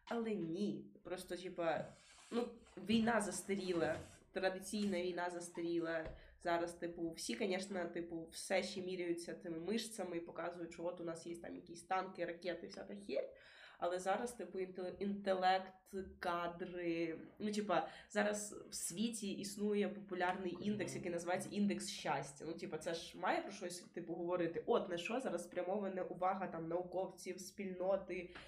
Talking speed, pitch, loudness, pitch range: 145 wpm, 180 Hz, -42 LUFS, 170-195 Hz